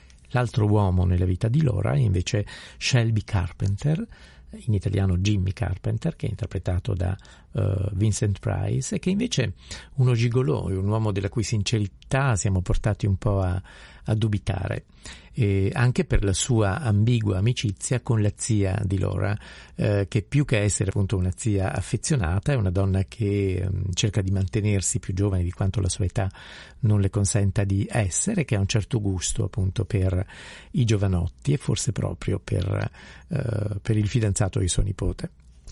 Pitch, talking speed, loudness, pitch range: 105 Hz, 165 wpm, -25 LUFS, 95-115 Hz